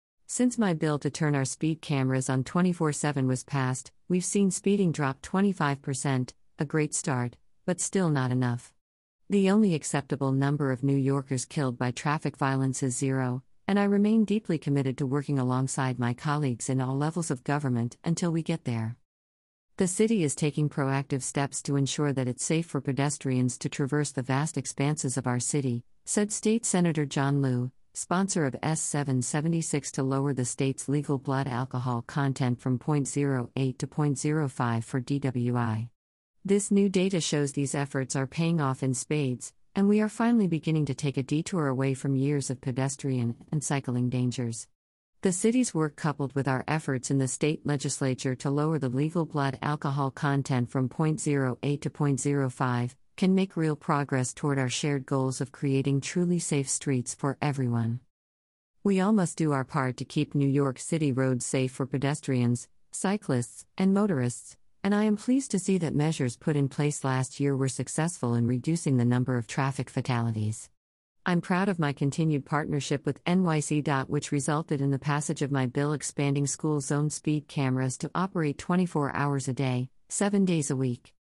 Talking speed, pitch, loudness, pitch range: 175 wpm, 140 Hz, -28 LUFS, 130-155 Hz